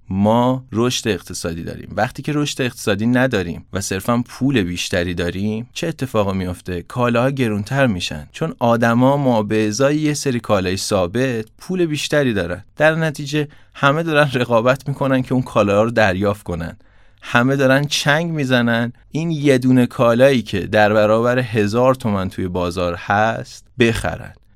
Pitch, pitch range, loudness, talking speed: 120 Hz, 100-135 Hz, -18 LUFS, 150 wpm